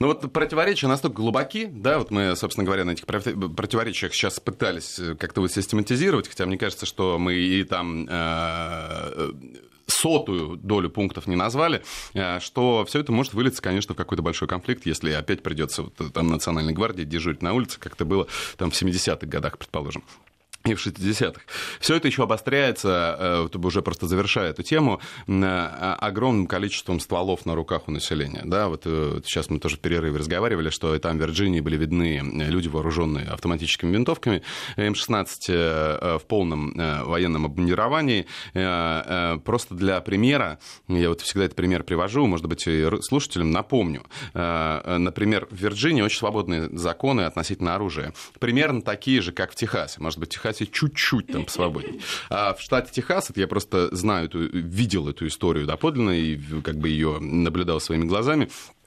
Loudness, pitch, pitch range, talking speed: -24 LUFS, 90 Hz, 80-105 Hz, 155 wpm